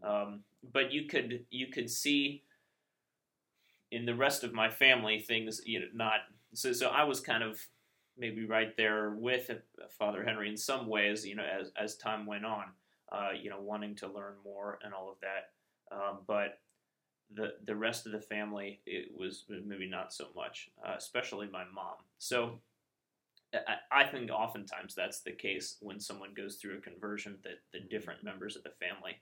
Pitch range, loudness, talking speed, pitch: 105-120 Hz, -36 LUFS, 185 wpm, 110 Hz